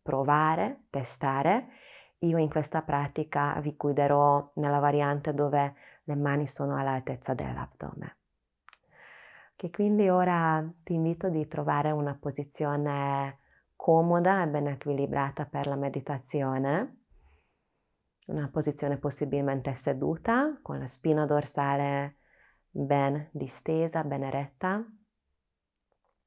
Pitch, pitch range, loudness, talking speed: 145 Hz, 140-160 Hz, -29 LUFS, 105 wpm